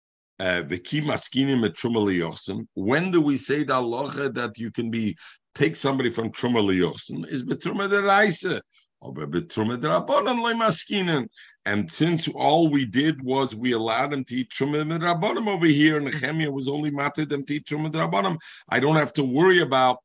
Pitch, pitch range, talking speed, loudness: 140 Hz, 120-155 Hz, 130 wpm, -24 LUFS